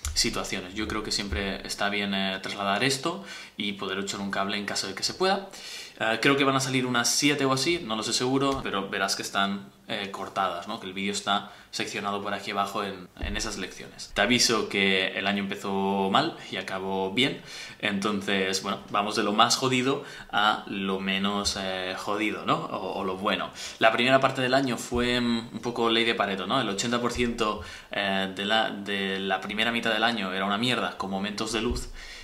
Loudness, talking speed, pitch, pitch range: -27 LUFS, 205 wpm, 100 Hz, 95-120 Hz